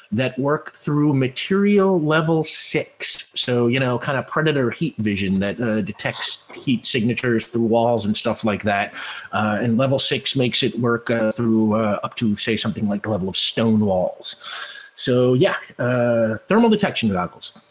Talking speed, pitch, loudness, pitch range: 175 wpm, 120 Hz, -20 LUFS, 110-135 Hz